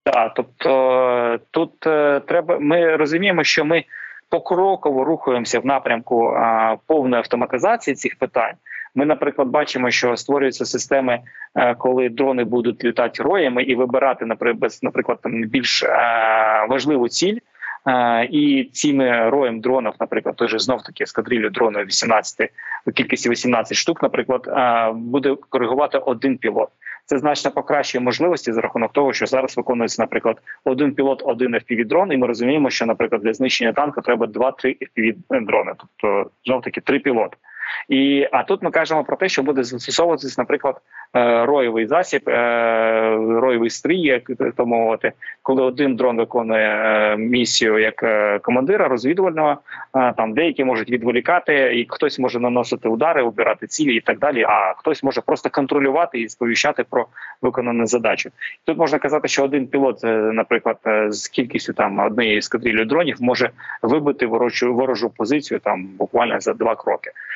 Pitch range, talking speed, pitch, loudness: 115-145 Hz, 145 wpm, 130 Hz, -19 LUFS